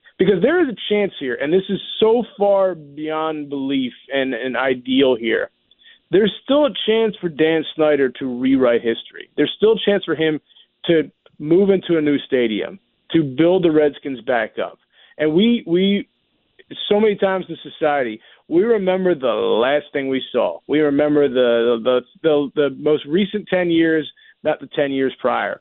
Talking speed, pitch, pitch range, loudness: 175 wpm, 155 Hz, 140-195 Hz, -18 LUFS